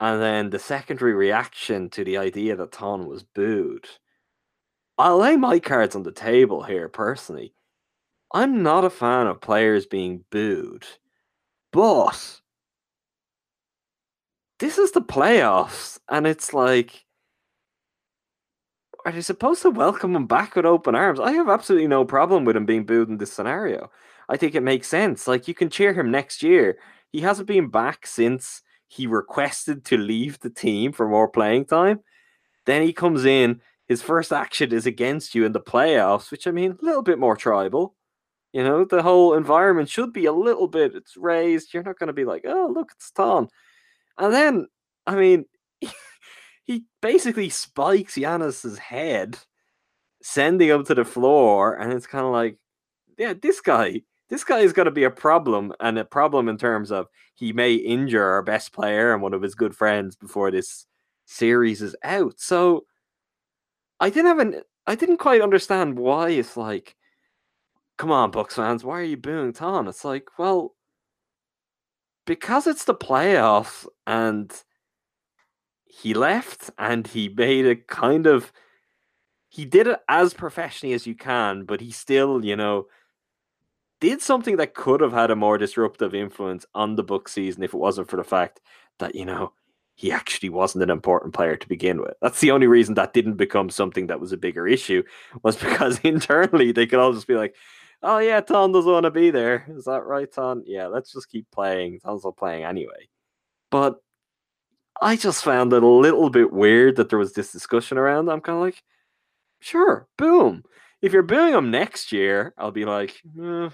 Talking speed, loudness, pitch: 180 wpm, -21 LUFS, 140 Hz